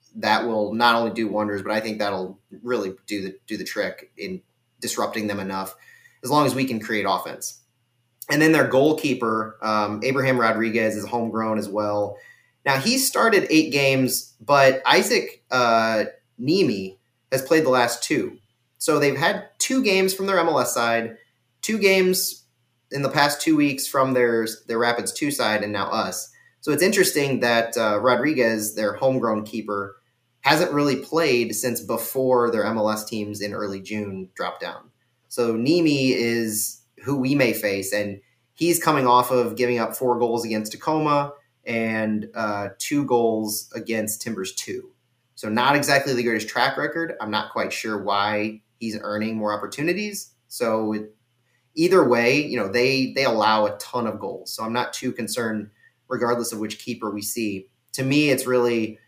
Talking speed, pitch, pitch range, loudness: 170 wpm, 120 Hz, 110-135 Hz, -22 LUFS